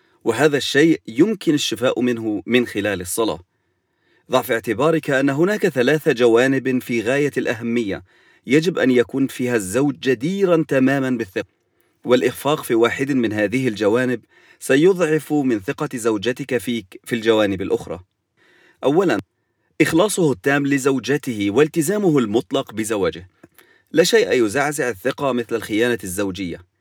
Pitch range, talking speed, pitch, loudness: 115-145 Hz, 120 wpm, 130 Hz, -19 LUFS